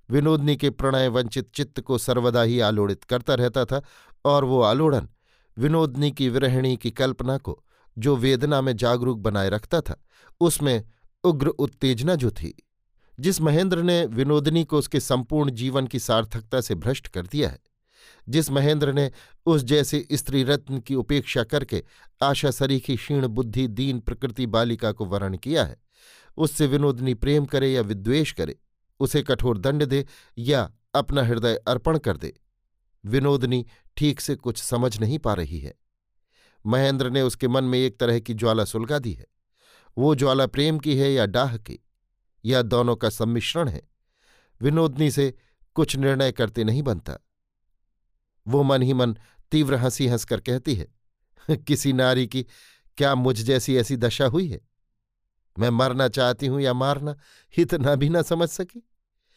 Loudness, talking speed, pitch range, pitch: -23 LUFS, 160 wpm, 115-145 Hz, 130 Hz